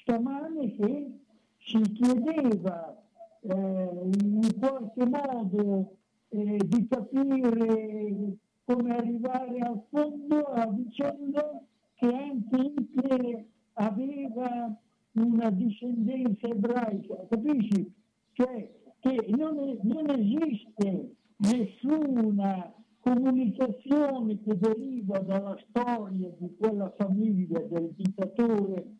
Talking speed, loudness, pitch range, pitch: 85 wpm, -29 LUFS, 210-255 Hz, 230 Hz